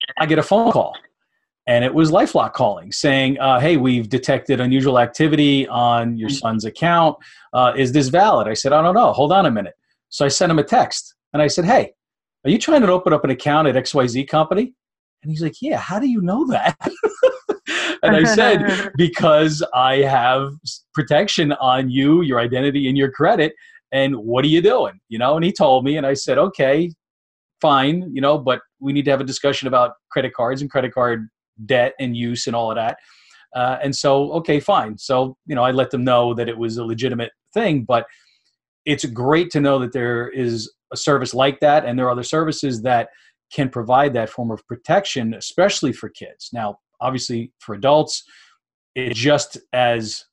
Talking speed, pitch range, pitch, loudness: 200 wpm, 125-155 Hz, 135 Hz, -18 LUFS